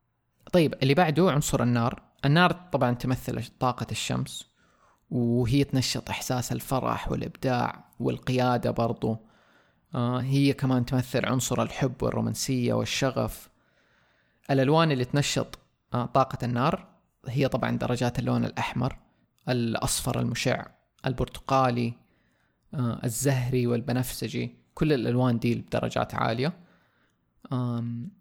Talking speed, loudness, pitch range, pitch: 100 wpm, -27 LUFS, 120-135 Hz, 125 Hz